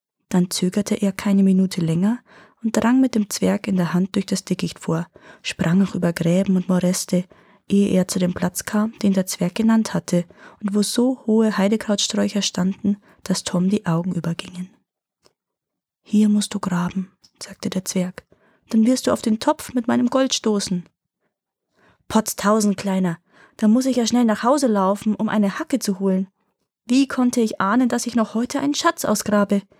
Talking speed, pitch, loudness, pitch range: 180 wpm, 205 Hz, -20 LUFS, 190-225 Hz